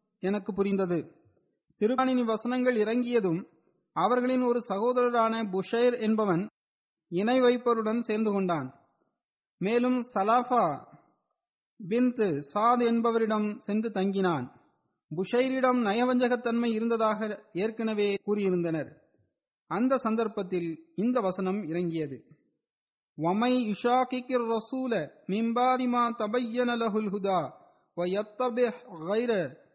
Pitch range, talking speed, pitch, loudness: 190-245 Hz, 60 wpm, 220 Hz, -28 LUFS